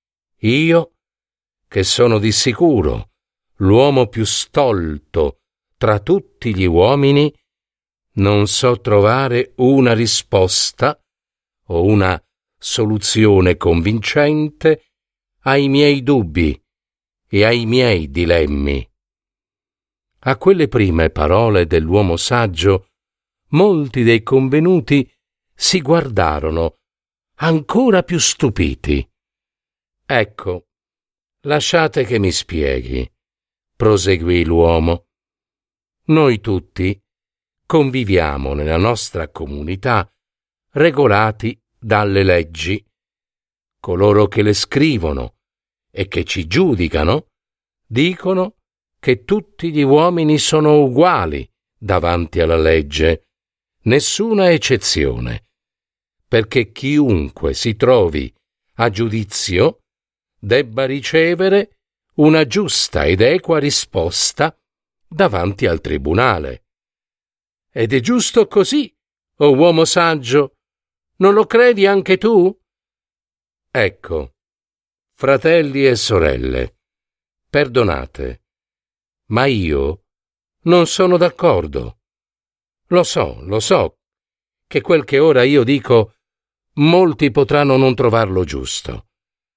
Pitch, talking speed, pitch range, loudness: 115 Hz, 90 wpm, 95-150 Hz, -15 LUFS